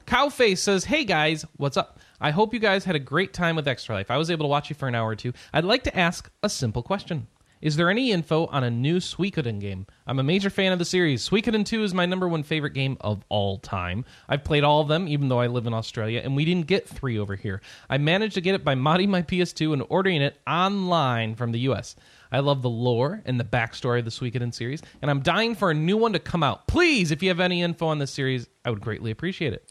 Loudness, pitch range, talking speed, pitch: -24 LUFS, 125-180 Hz, 265 wpm, 155 Hz